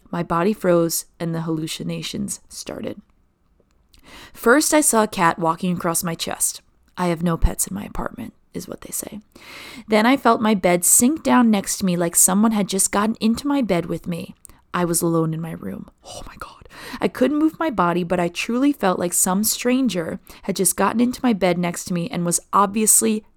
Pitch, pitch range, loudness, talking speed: 190 Hz, 170-225 Hz, -19 LUFS, 205 wpm